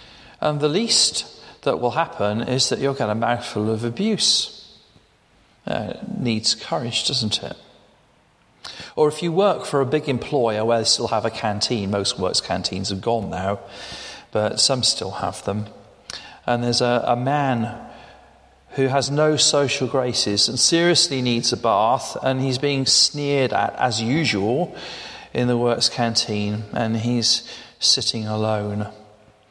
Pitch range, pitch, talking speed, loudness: 110-140 Hz, 120 Hz, 150 wpm, -20 LUFS